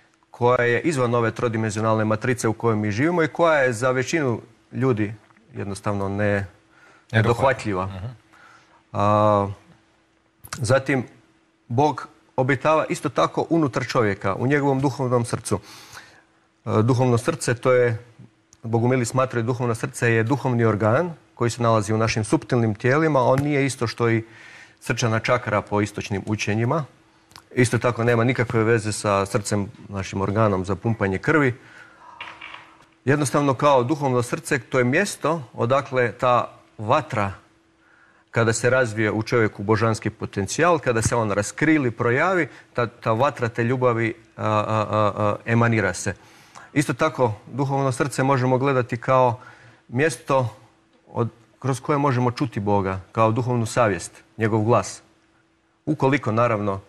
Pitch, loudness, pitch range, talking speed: 120 Hz, -22 LUFS, 110-130 Hz, 130 wpm